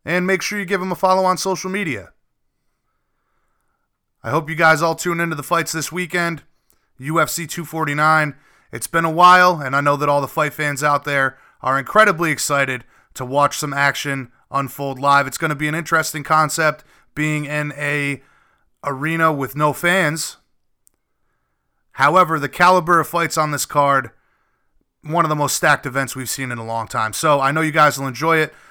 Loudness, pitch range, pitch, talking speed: -18 LUFS, 140-170 Hz, 150 Hz, 185 wpm